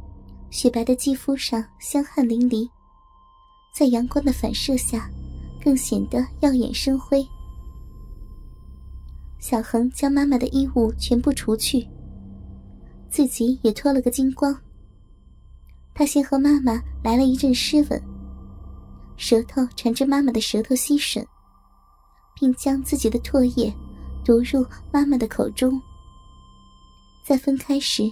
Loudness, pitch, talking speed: -21 LUFS, 245 Hz, 180 characters per minute